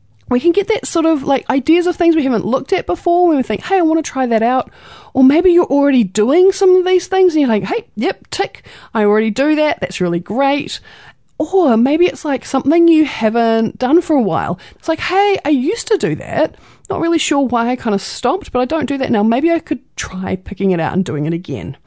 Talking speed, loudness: 250 wpm, -15 LUFS